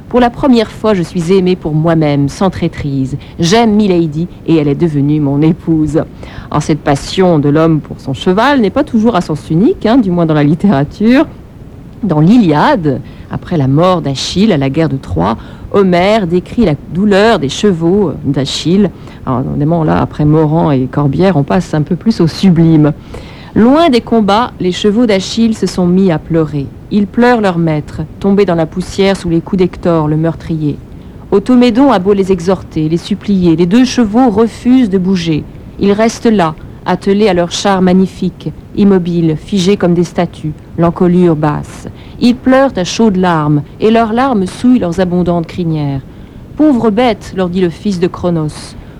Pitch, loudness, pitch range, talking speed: 180 Hz, -11 LUFS, 155-205 Hz, 175 wpm